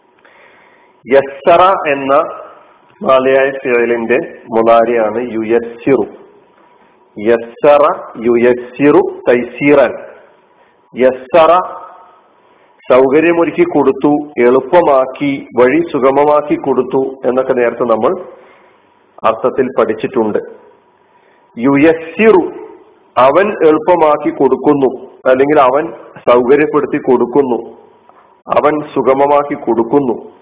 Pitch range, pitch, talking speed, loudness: 125-170 Hz, 140 Hz, 55 wpm, -11 LUFS